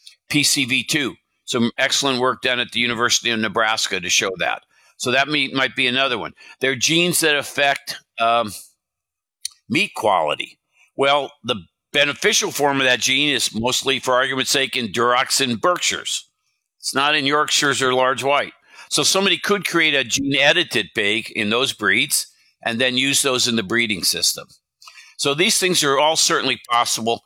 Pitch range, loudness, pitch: 120-145 Hz, -18 LUFS, 135 Hz